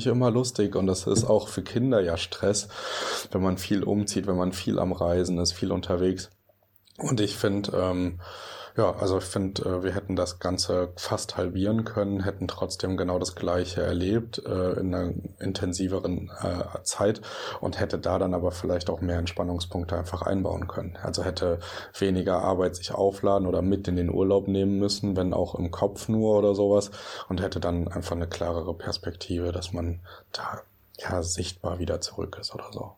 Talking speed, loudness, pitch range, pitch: 175 wpm, -27 LUFS, 90-100 Hz, 95 Hz